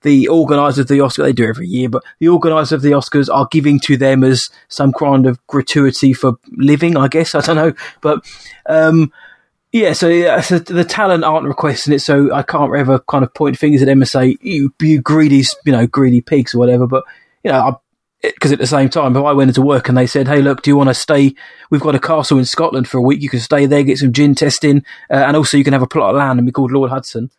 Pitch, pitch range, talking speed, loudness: 140 Hz, 135-155 Hz, 250 wpm, -12 LUFS